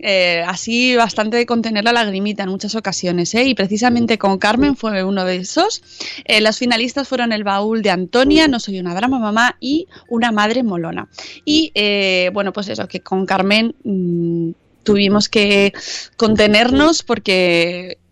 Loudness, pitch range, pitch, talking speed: -16 LUFS, 190-240 Hz, 210 Hz, 160 wpm